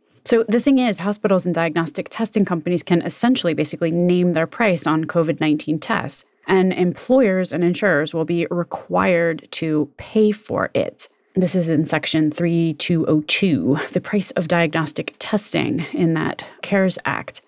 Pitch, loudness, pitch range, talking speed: 175 Hz, -19 LUFS, 160-200 Hz, 150 wpm